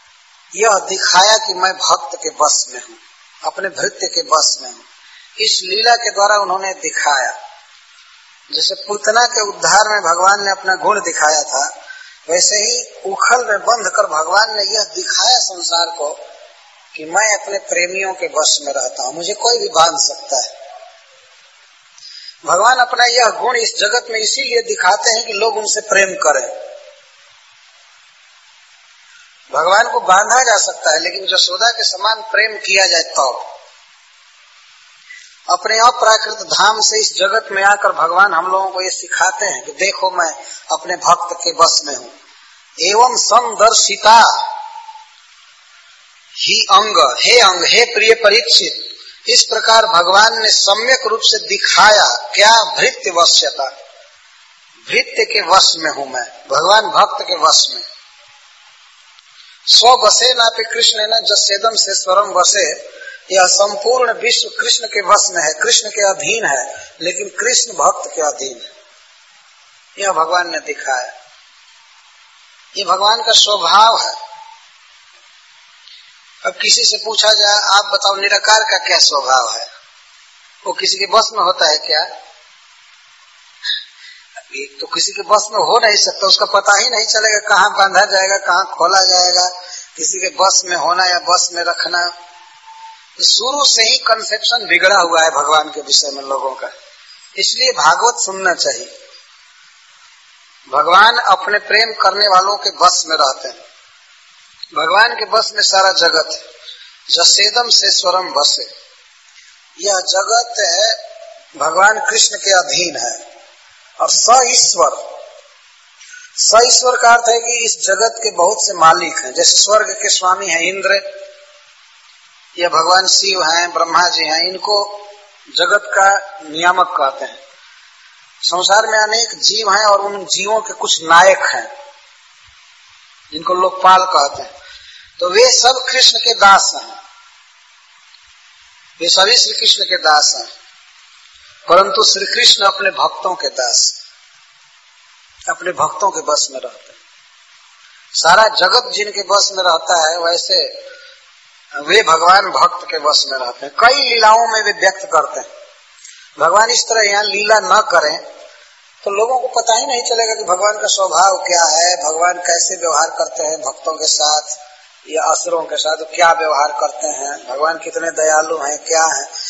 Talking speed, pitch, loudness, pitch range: 150 wpm, 205 Hz, -12 LUFS, 185-250 Hz